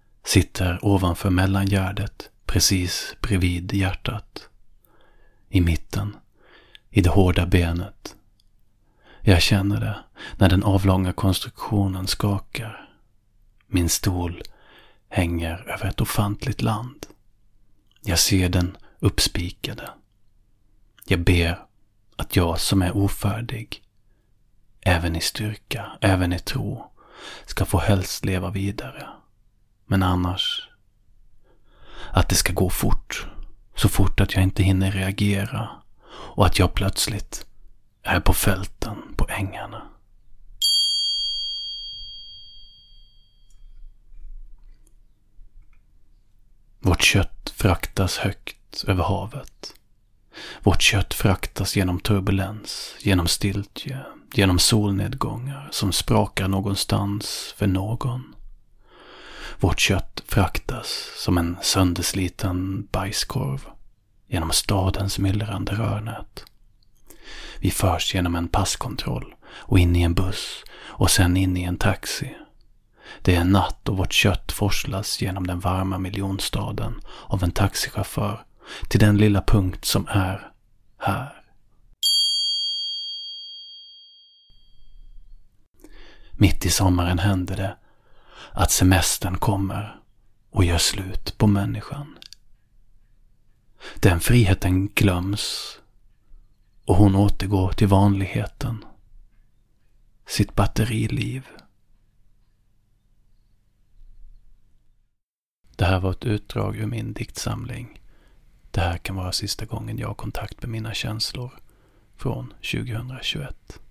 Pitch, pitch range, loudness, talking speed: 100 Hz, 95-110 Hz, -23 LUFS, 95 wpm